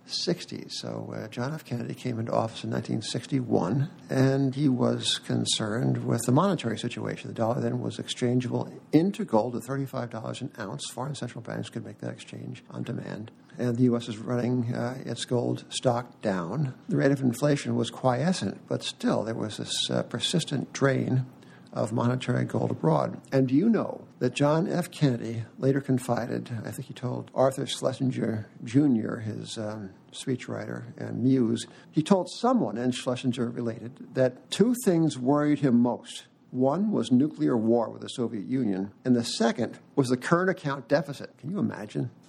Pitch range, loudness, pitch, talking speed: 115-140 Hz, -28 LUFS, 125 Hz, 170 wpm